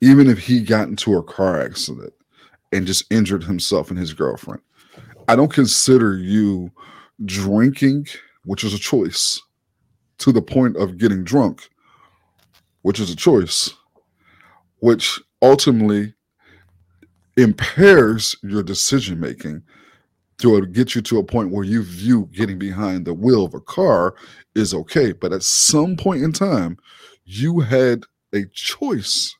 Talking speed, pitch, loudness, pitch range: 140 wpm, 105 Hz, -17 LUFS, 95-125 Hz